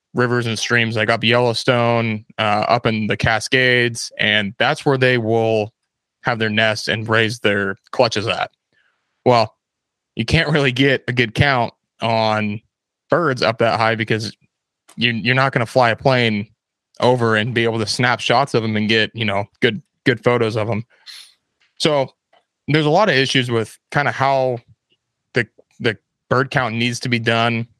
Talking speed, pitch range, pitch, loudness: 175 wpm, 110-125 Hz, 115 Hz, -18 LUFS